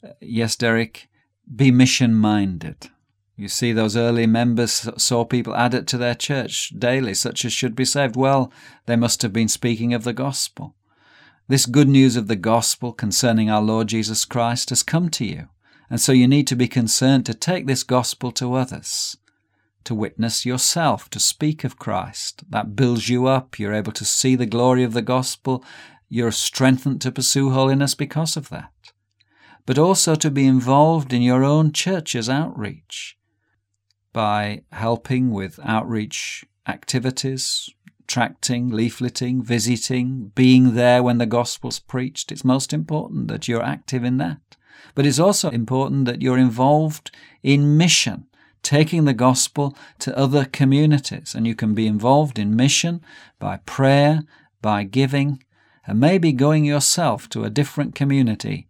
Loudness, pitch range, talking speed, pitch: -19 LUFS, 115-140 Hz, 155 wpm, 125 Hz